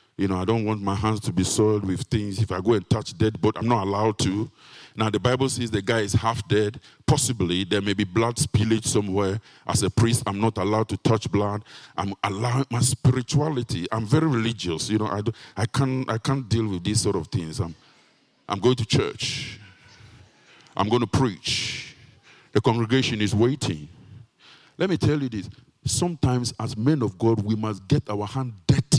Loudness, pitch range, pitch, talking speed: -24 LUFS, 105-130 Hz, 115 Hz, 200 wpm